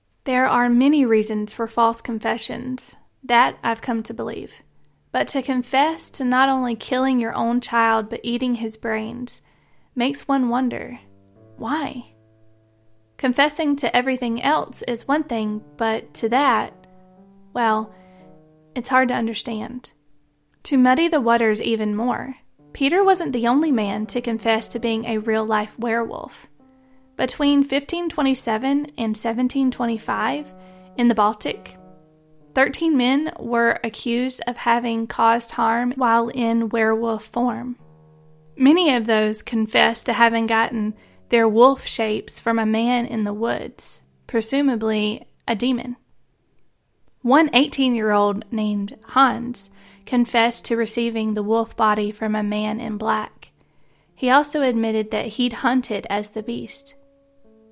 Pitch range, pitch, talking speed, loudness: 220-255 Hz, 235 Hz, 130 wpm, -21 LUFS